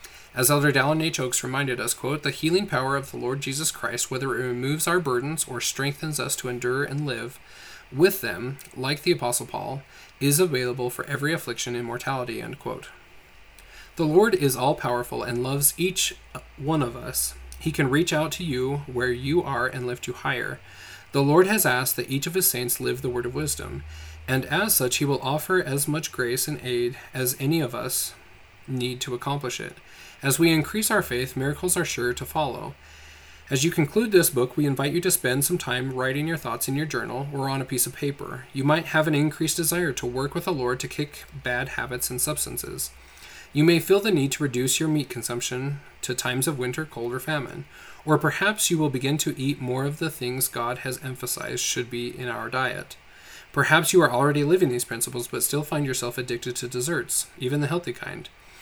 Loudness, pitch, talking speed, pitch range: -25 LUFS, 135 Hz, 210 wpm, 125-155 Hz